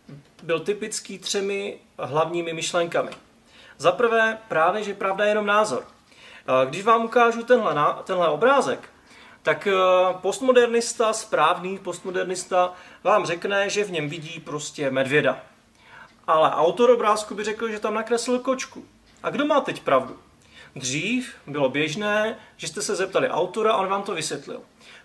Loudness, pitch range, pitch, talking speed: -23 LUFS, 165-225 Hz, 200 Hz, 140 wpm